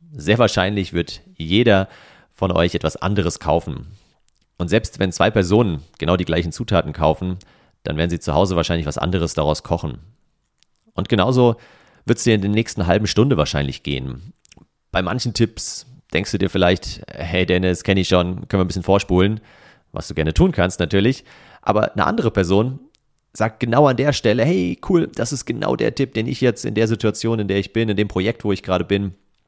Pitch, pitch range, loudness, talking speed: 100 Hz, 90-115 Hz, -19 LUFS, 195 wpm